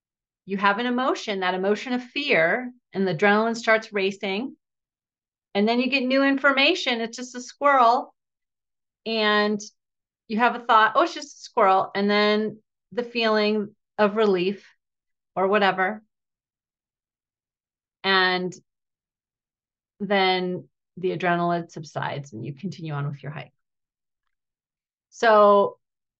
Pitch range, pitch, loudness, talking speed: 185-235 Hz, 205 Hz, -22 LUFS, 125 wpm